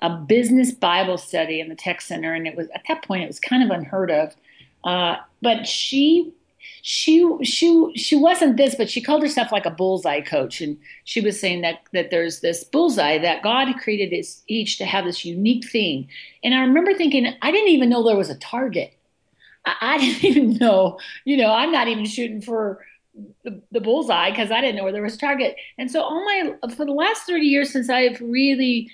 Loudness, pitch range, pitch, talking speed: -20 LUFS, 185-275 Hz, 230 Hz, 210 wpm